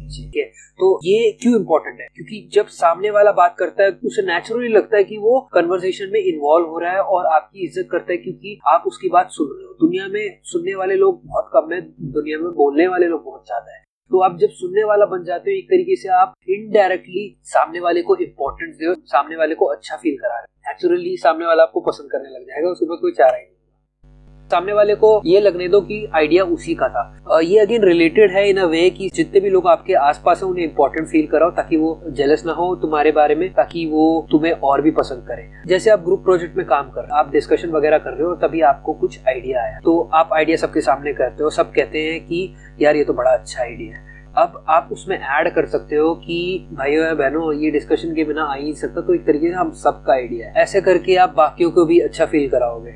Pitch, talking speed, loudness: 190 Hz, 245 wpm, -17 LUFS